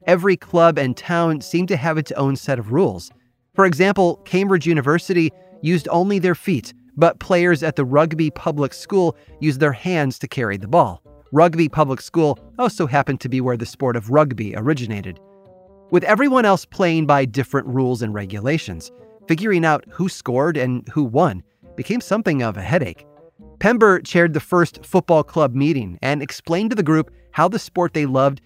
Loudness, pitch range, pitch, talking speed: -19 LUFS, 135-180 Hz, 160 Hz, 180 wpm